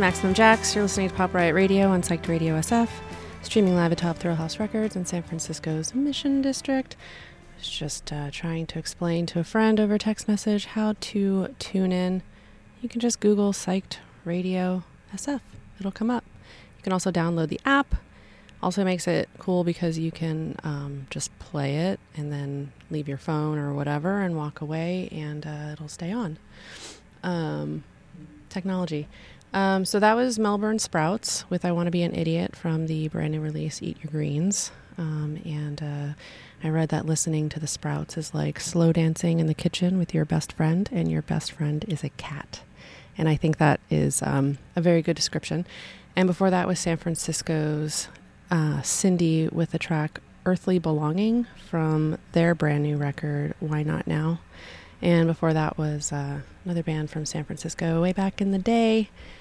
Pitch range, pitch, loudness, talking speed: 155-185 Hz, 165 Hz, -26 LUFS, 180 wpm